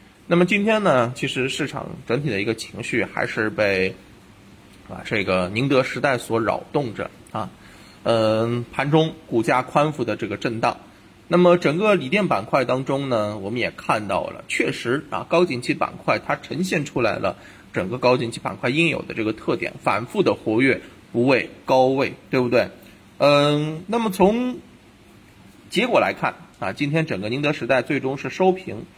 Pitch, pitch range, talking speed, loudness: 135 Hz, 115-165 Hz, 255 characters per minute, -21 LUFS